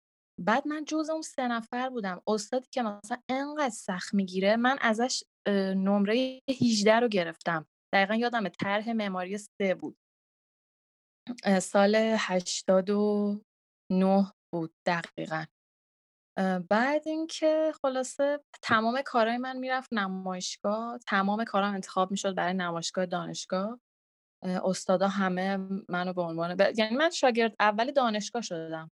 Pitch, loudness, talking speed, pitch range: 205 Hz, -29 LUFS, 115 wpm, 185-245 Hz